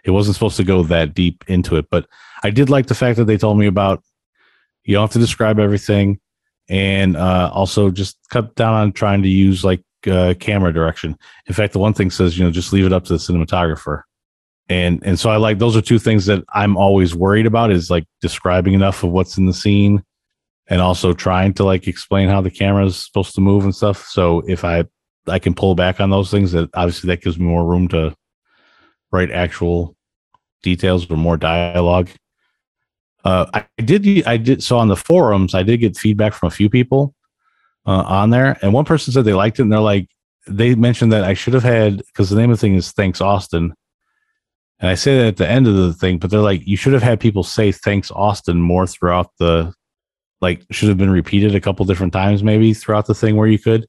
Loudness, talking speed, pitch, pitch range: -15 LUFS, 225 wpm, 100 Hz, 90-110 Hz